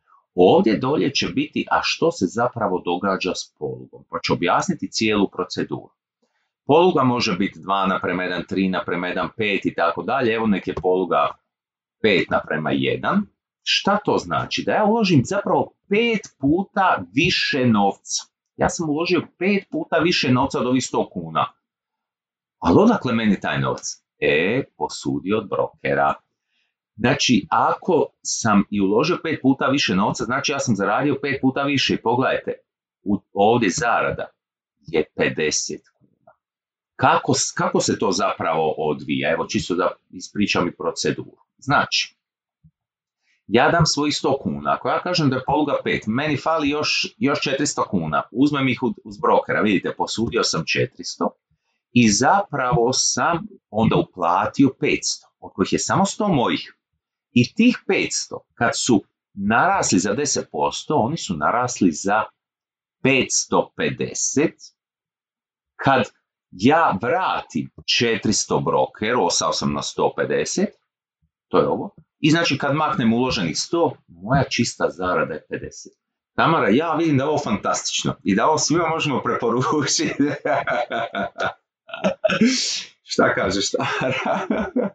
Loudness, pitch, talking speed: -20 LUFS, 140 Hz, 135 wpm